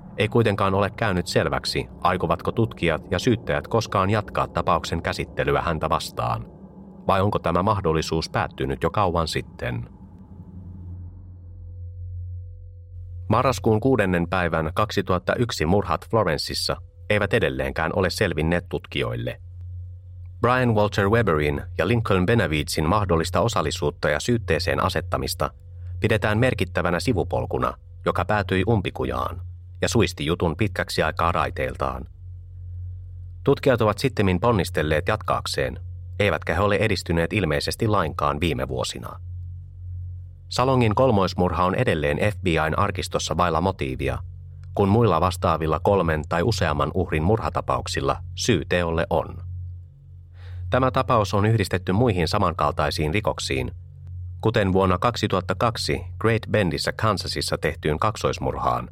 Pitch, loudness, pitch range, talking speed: 90 Hz, -23 LUFS, 85-105 Hz, 105 wpm